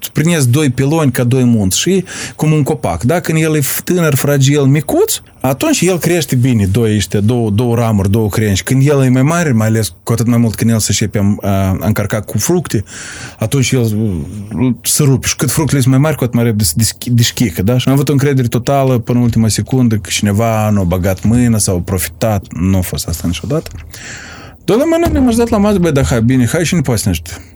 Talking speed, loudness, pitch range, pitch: 230 wpm, -13 LUFS, 105-140 Hz, 120 Hz